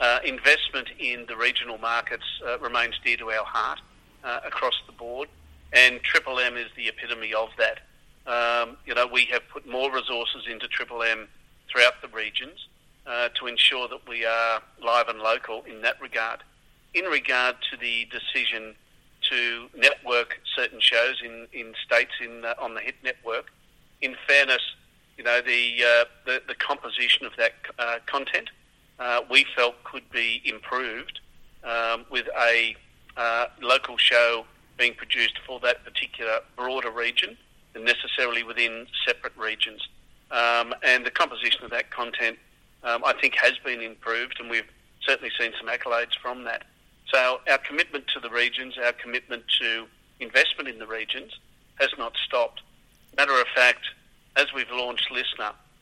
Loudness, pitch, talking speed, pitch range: -24 LUFS, 120 Hz, 160 wpm, 115-125 Hz